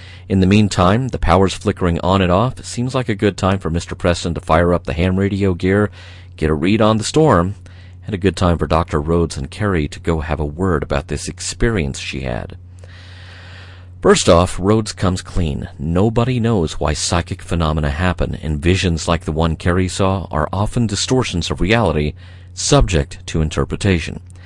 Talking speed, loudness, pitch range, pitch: 185 wpm, -17 LUFS, 85-95 Hz, 90 Hz